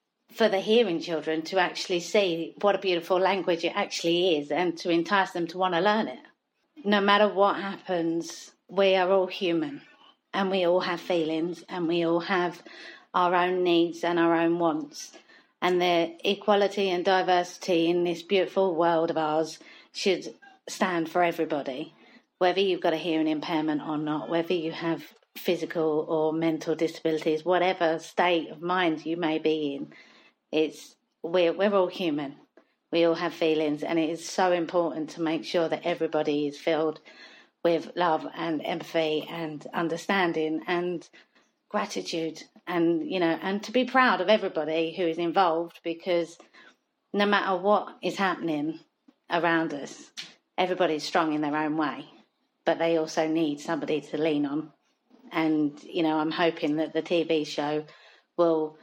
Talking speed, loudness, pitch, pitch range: 160 wpm, -27 LUFS, 170 Hz, 160-185 Hz